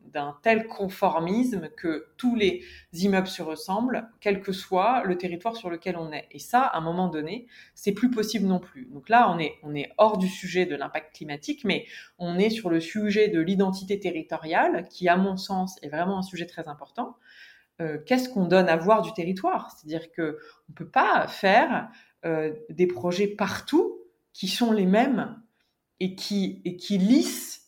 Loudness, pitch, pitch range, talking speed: -26 LUFS, 190 Hz, 170-225 Hz, 195 wpm